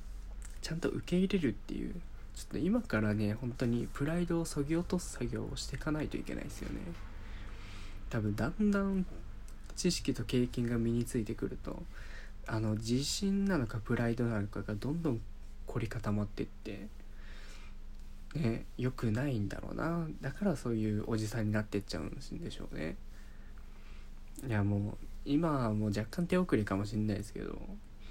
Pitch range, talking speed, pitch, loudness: 105-145 Hz, 345 characters per minute, 115 Hz, -36 LUFS